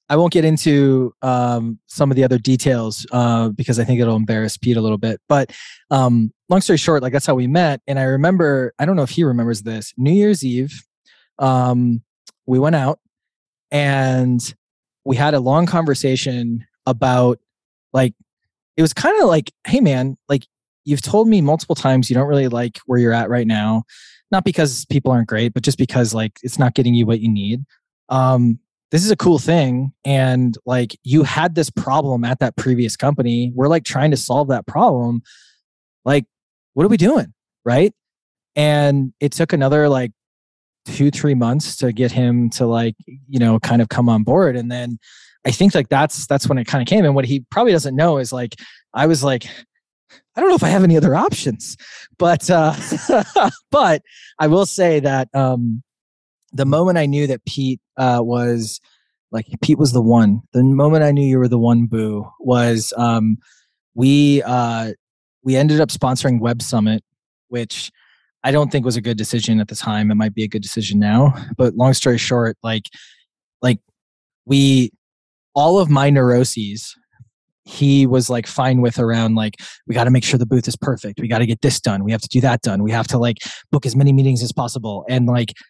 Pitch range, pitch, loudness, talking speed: 120-145 Hz, 130 Hz, -17 LUFS, 195 wpm